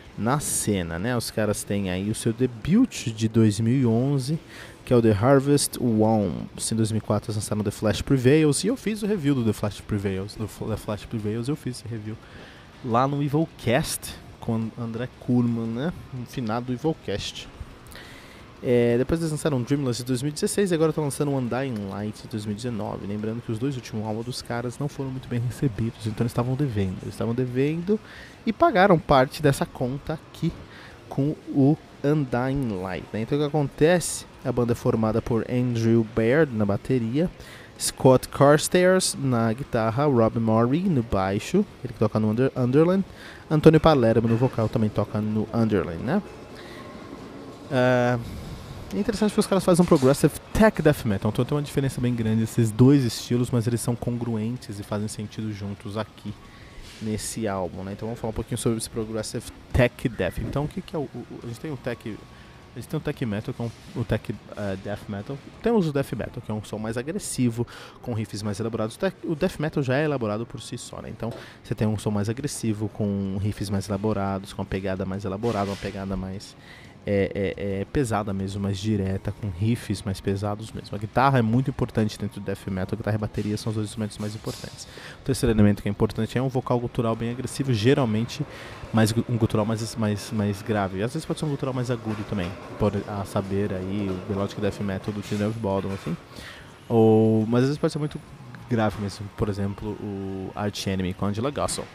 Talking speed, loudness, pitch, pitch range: 200 wpm, -25 LUFS, 115 Hz, 105-135 Hz